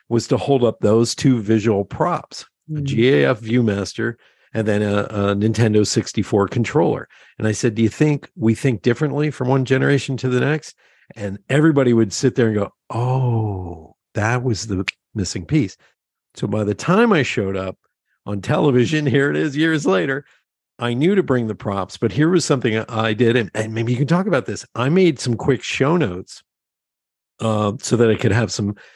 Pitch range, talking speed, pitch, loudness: 110-135 Hz, 195 wpm, 120 Hz, -19 LUFS